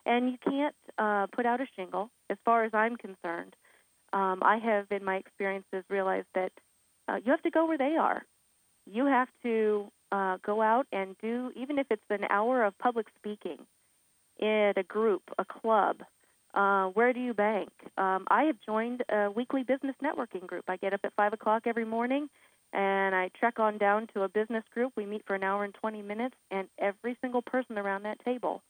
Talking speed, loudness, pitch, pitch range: 200 wpm, -31 LUFS, 215 Hz, 195-245 Hz